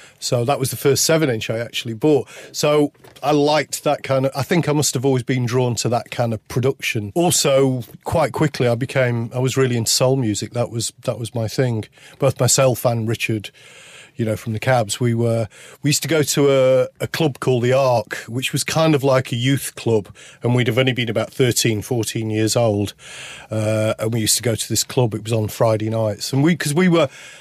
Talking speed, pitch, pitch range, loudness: 230 wpm, 125 Hz, 115-140 Hz, -19 LUFS